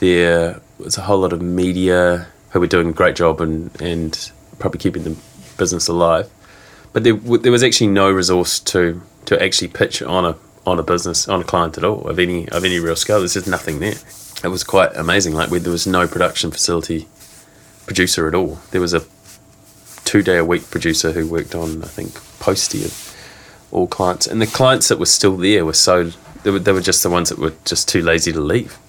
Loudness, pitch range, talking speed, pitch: -16 LUFS, 85-95 Hz, 220 wpm, 90 Hz